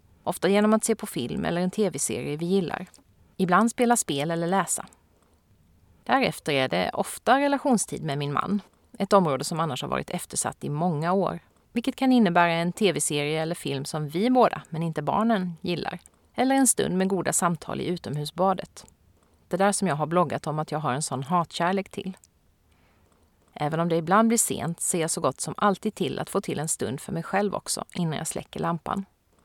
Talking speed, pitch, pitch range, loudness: 195 wpm, 175 Hz, 145-195 Hz, -25 LUFS